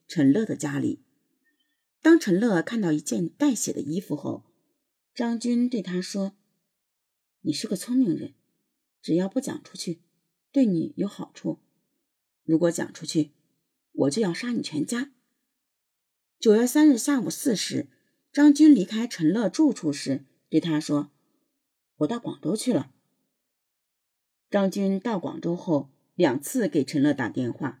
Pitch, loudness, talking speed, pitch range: 235 Hz, -25 LUFS, 200 characters per minute, 170-285 Hz